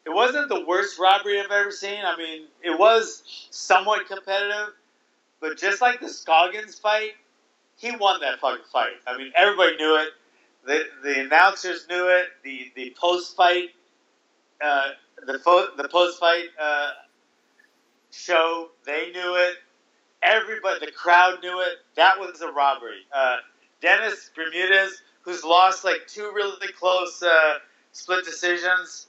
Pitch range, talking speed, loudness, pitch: 165-200 Hz, 150 wpm, -22 LUFS, 180 Hz